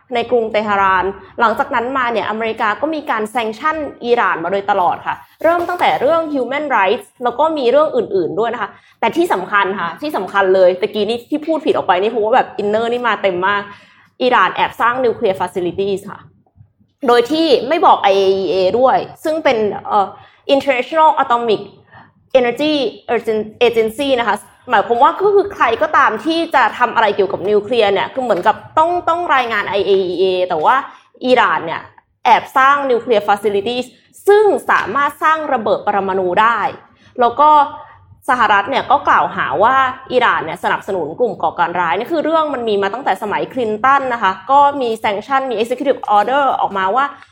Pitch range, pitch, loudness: 205-295 Hz, 245 Hz, -15 LUFS